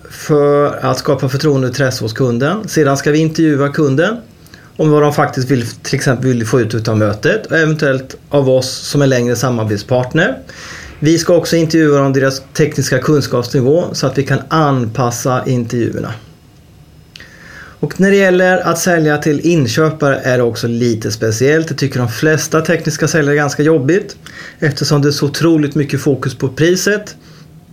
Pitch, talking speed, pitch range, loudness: 145 Hz, 170 wpm, 130-155 Hz, -13 LUFS